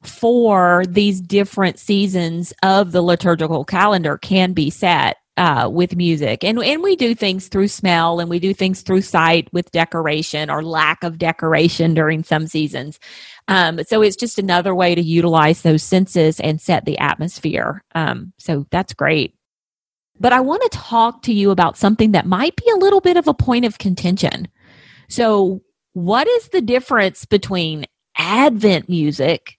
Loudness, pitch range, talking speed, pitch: -16 LUFS, 165-205 Hz, 165 wpm, 180 Hz